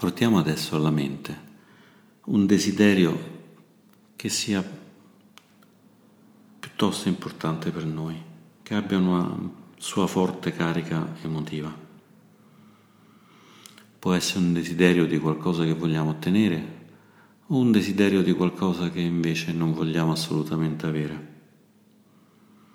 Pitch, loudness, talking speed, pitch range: 85 Hz, -25 LUFS, 105 wpm, 80-105 Hz